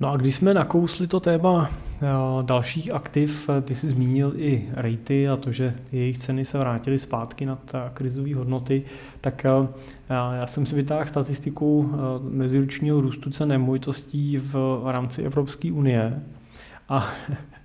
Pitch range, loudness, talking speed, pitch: 130-145 Hz, -24 LUFS, 135 wpm, 135 Hz